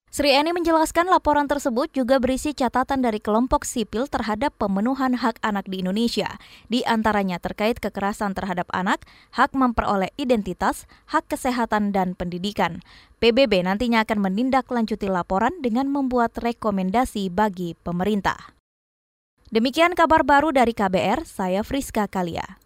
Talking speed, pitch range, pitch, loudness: 125 wpm, 200-270 Hz, 230 Hz, -22 LUFS